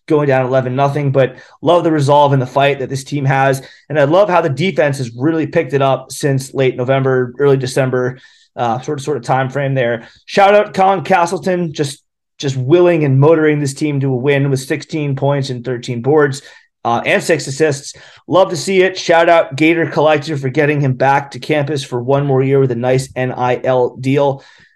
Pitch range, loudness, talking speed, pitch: 130-160 Hz, -14 LUFS, 205 wpm, 140 Hz